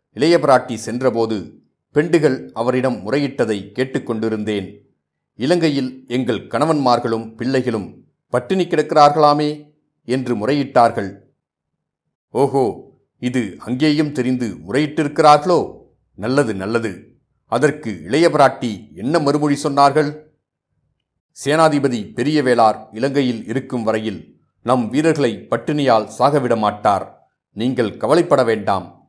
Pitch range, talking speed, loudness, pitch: 115-150 Hz, 80 wpm, -18 LUFS, 130 Hz